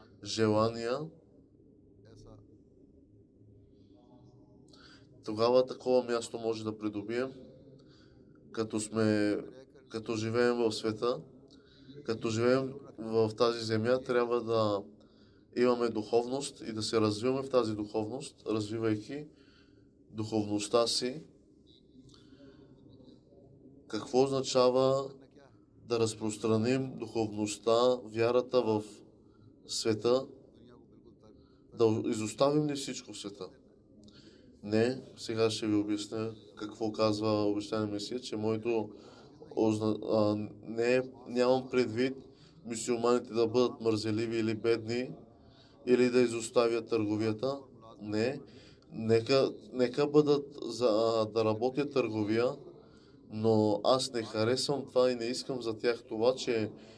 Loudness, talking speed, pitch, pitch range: -31 LUFS, 95 wpm, 115 Hz, 110-130 Hz